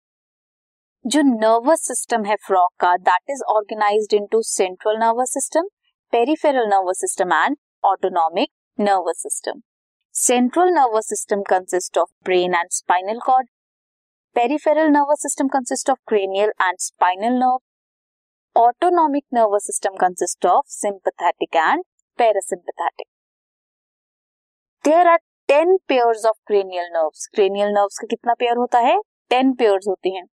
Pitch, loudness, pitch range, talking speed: 225 Hz, -19 LUFS, 195-275 Hz, 130 wpm